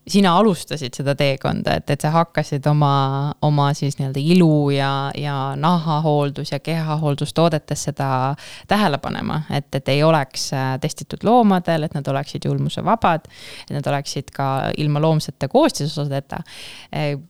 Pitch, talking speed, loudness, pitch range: 145 Hz, 140 wpm, -20 LUFS, 140-160 Hz